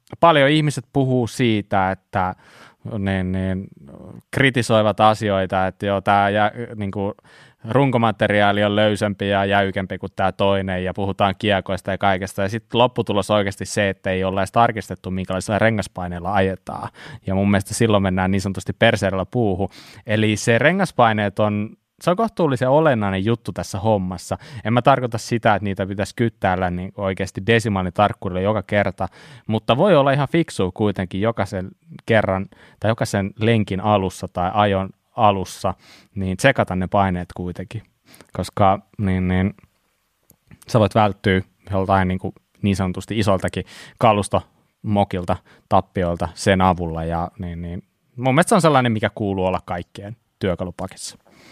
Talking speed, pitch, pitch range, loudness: 145 wpm, 100 Hz, 95-115 Hz, -20 LUFS